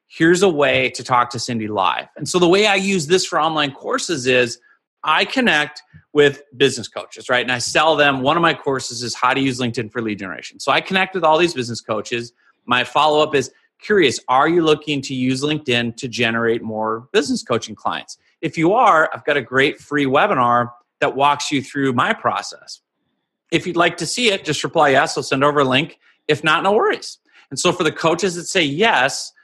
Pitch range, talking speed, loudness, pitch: 125-165 Hz, 220 wpm, -18 LUFS, 145 Hz